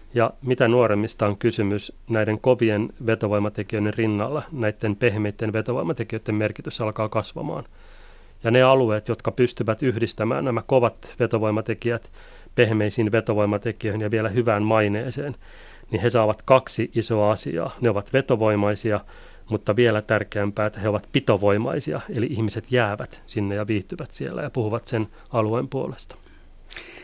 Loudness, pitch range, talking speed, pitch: -23 LUFS, 105-120 Hz, 130 wpm, 110 Hz